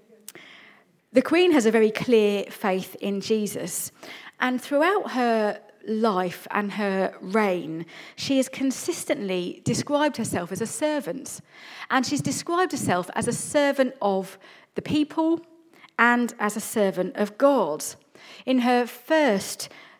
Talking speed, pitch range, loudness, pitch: 130 wpm, 205-280 Hz, -24 LUFS, 230 Hz